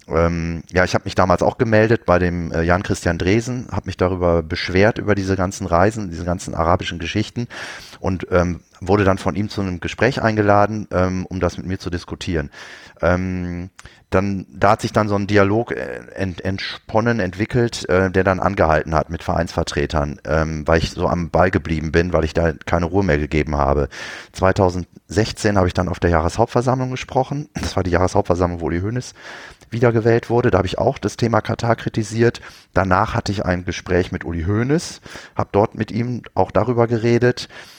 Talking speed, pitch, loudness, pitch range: 185 wpm, 95 Hz, -19 LUFS, 85-110 Hz